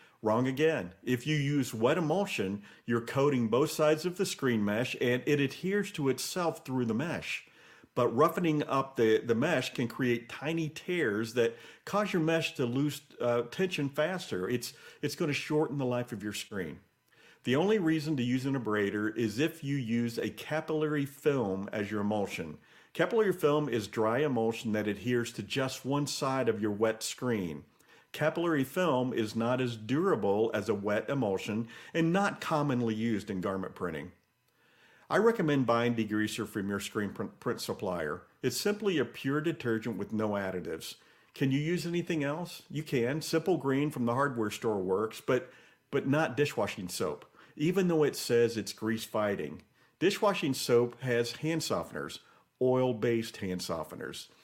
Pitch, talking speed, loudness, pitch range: 130 Hz, 170 wpm, -31 LUFS, 115-155 Hz